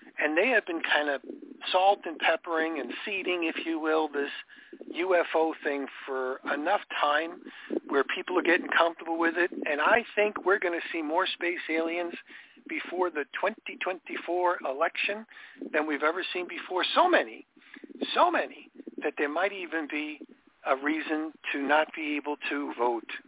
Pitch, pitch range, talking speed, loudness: 170 Hz, 155-240 Hz, 160 wpm, -28 LUFS